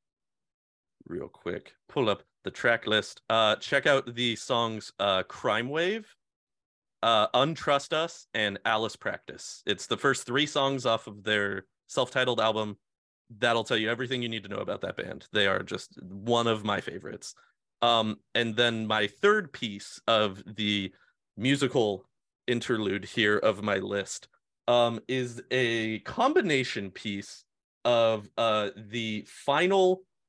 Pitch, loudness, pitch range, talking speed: 115 Hz, -28 LUFS, 105-130 Hz, 145 wpm